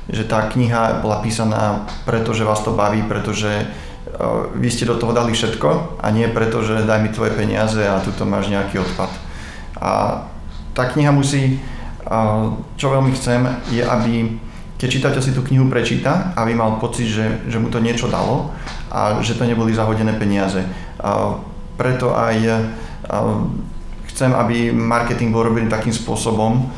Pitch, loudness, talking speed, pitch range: 115 Hz, -18 LUFS, 155 wpm, 105-120 Hz